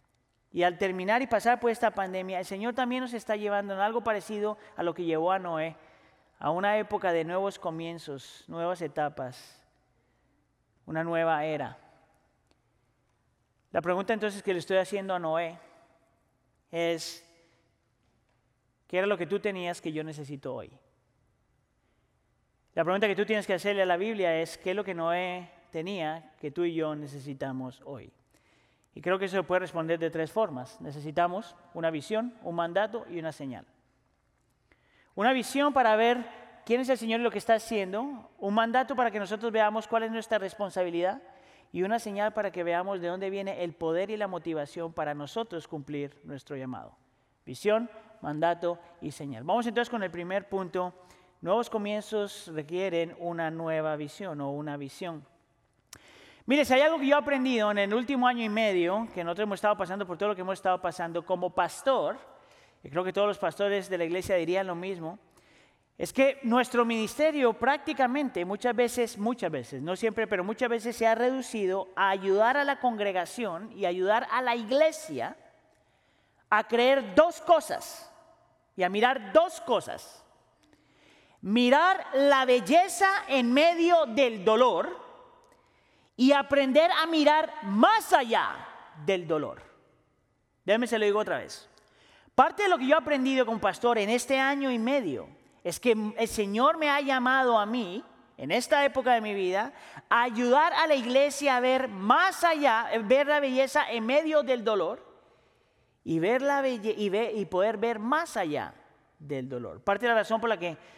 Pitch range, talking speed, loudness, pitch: 170-245 Hz, 170 wpm, -28 LUFS, 205 Hz